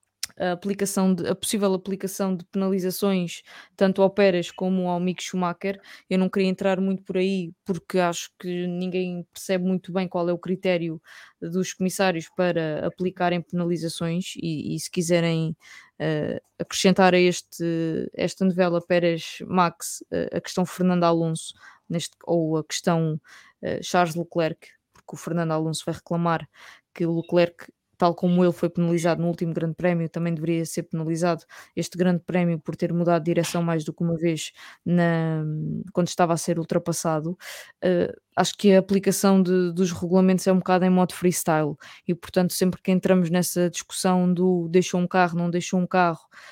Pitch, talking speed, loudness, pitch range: 180 Hz, 170 wpm, -24 LUFS, 170-185 Hz